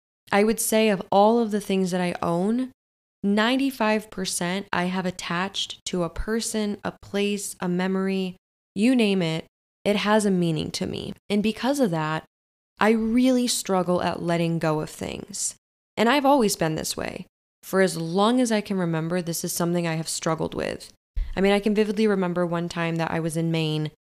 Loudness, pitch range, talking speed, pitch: -24 LUFS, 170-215 Hz, 190 wpm, 190 Hz